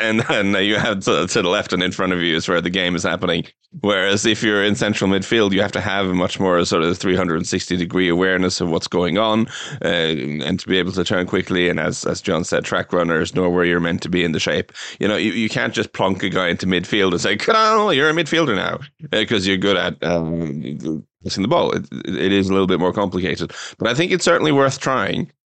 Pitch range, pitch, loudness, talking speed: 90-110 Hz, 95 Hz, -18 LUFS, 245 wpm